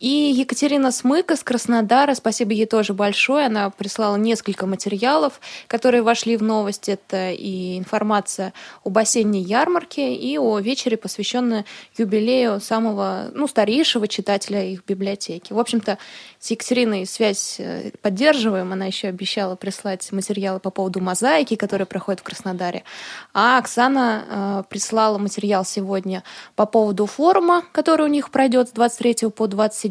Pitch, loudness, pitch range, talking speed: 215 Hz, -20 LUFS, 200-245 Hz, 135 wpm